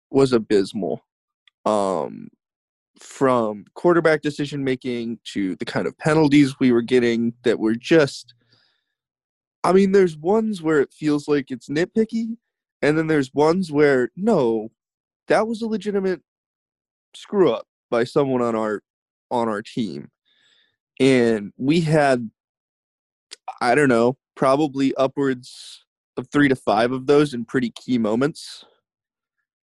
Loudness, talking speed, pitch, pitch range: -20 LUFS, 130 wpm, 140 Hz, 125-165 Hz